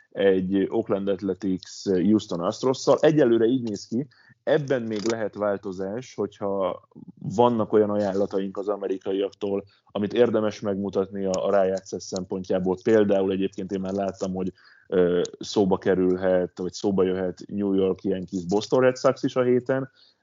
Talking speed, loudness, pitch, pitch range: 145 wpm, -25 LUFS, 100 Hz, 95-110 Hz